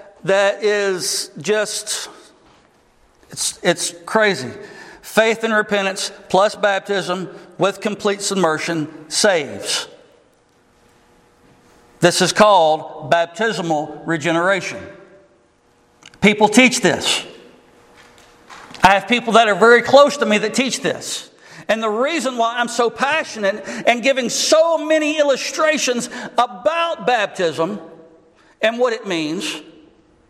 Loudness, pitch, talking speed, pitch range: -17 LUFS, 205 Hz, 105 wpm, 175-245 Hz